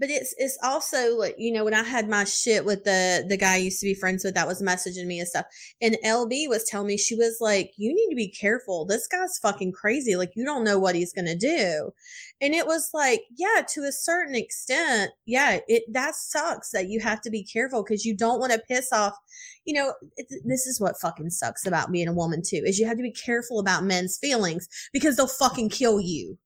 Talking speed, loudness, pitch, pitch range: 245 wpm, -25 LUFS, 225 Hz, 190-260 Hz